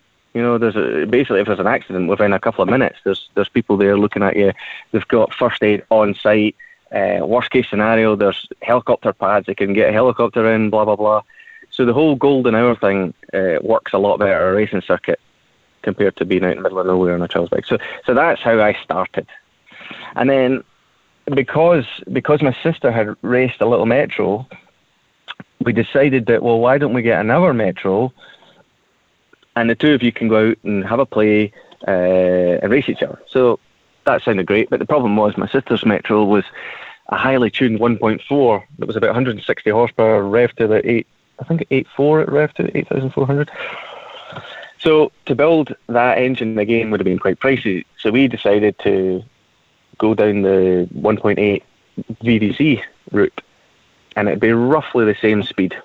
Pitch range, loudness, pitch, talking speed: 105-130 Hz, -16 LUFS, 115 Hz, 185 wpm